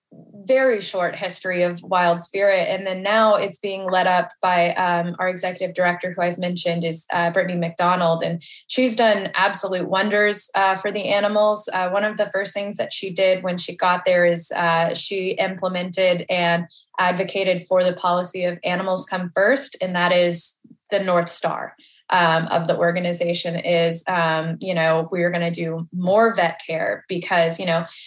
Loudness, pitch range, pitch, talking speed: -20 LUFS, 175-195 Hz, 180 Hz, 180 wpm